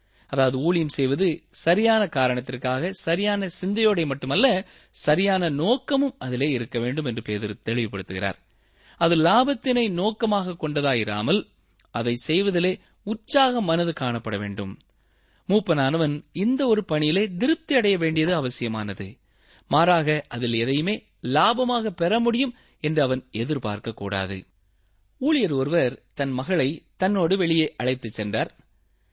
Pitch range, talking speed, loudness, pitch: 120-200 Hz, 105 wpm, -23 LUFS, 155 Hz